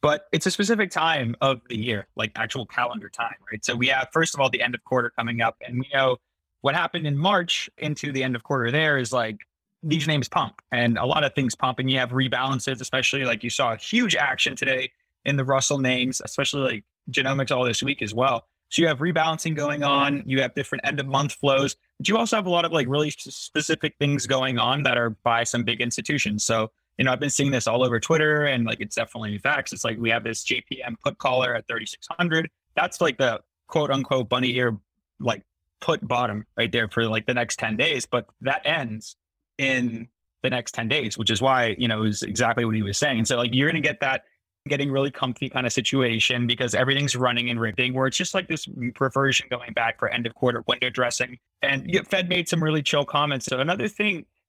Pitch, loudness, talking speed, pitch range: 130 Hz, -24 LUFS, 230 wpm, 120-145 Hz